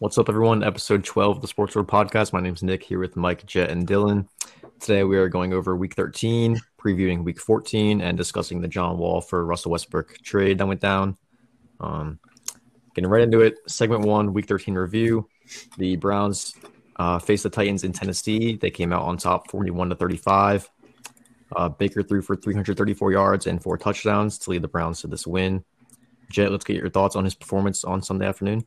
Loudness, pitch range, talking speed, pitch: -23 LUFS, 90-105 Hz, 200 wpm, 100 Hz